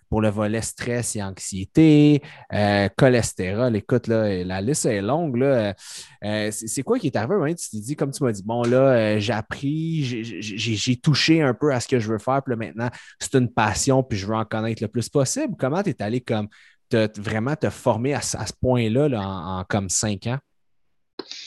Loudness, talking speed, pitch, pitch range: -22 LUFS, 220 wpm, 120 Hz, 105-140 Hz